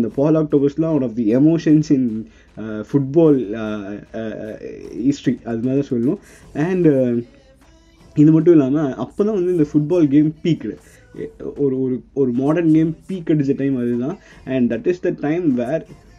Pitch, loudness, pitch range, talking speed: 140 Hz, -18 LUFS, 120-160 Hz, 150 wpm